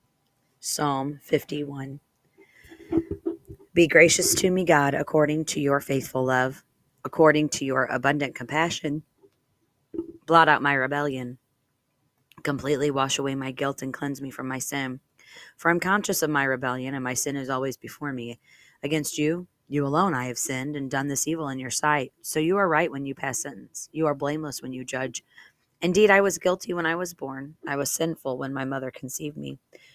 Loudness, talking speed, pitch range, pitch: -25 LUFS, 180 wpm, 135-160 Hz, 140 Hz